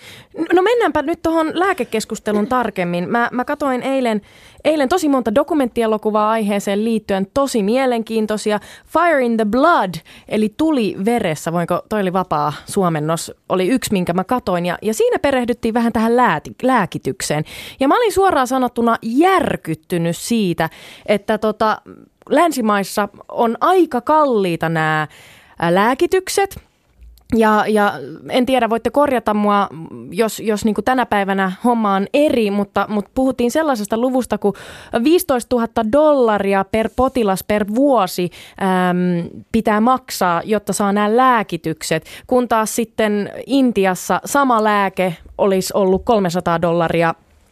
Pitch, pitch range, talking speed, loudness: 220 Hz, 190-255 Hz, 130 wpm, -17 LUFS